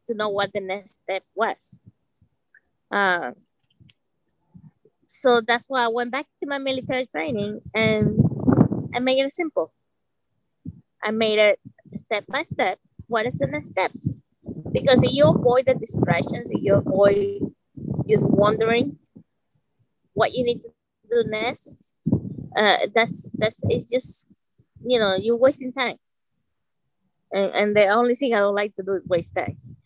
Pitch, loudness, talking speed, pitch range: 220 Hz, -22 LUFS, 150 wpm, 200-255 Hz